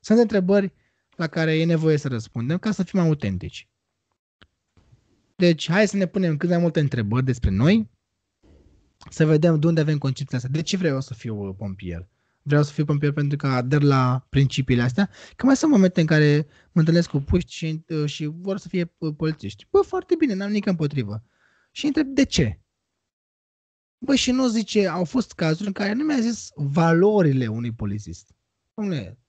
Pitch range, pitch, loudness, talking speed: 130-195 Hz, 160 Hz, -22 LUFS, 180 wpm